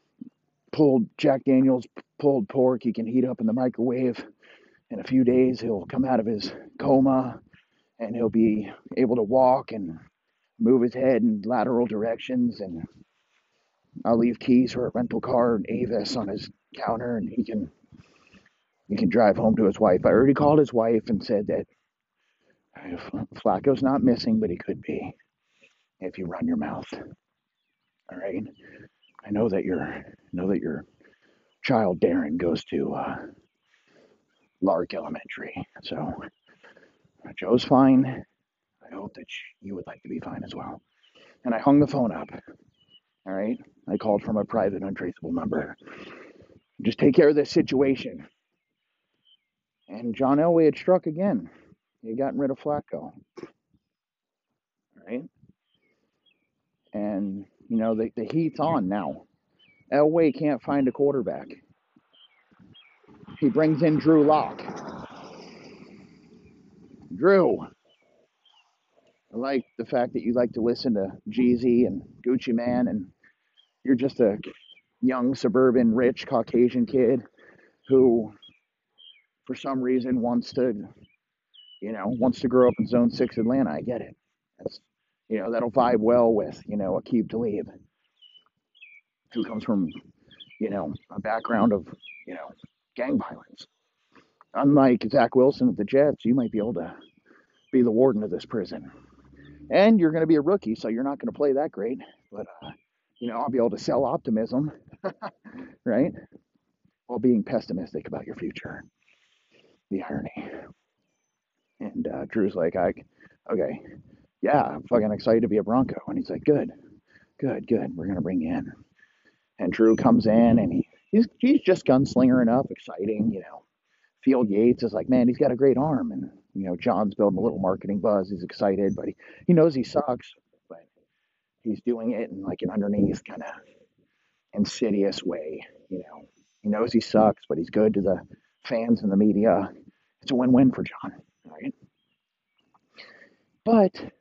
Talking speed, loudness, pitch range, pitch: 155 wpm, -24 LUFS, 115-140 Hz, 125 Hz